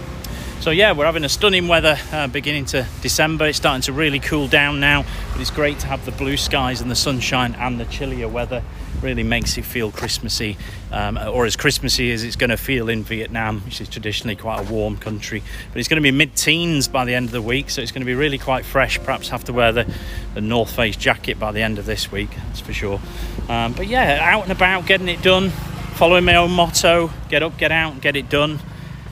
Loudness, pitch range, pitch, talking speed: -18 LUFS, 110-150 Hz, 125 Hz, 240 wpm